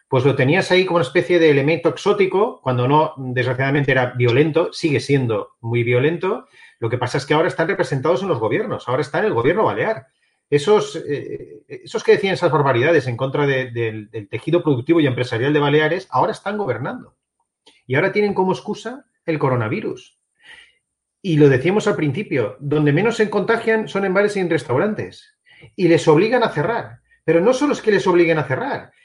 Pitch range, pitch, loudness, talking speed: 135-195 Hz, 160 Hz, -18 LUFS, 195 wpm